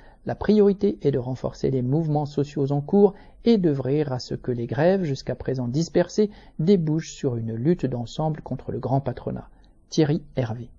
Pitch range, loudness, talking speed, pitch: 130-170 Hz, -24 LUFS, 175 wpm, 150 Hz